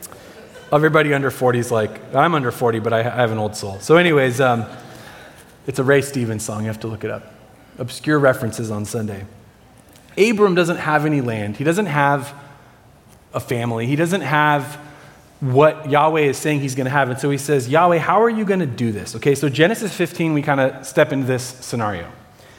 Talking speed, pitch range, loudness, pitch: 200 wpm, 115-150 Hz, -18 LUFS, 135 Hz